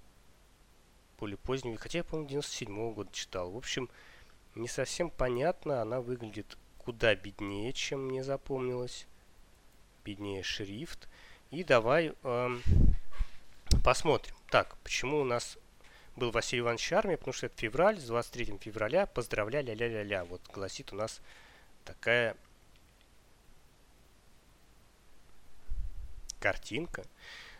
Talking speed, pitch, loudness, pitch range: 105 wpm, 115 Hz, -34 LUFS, 100-130 Hz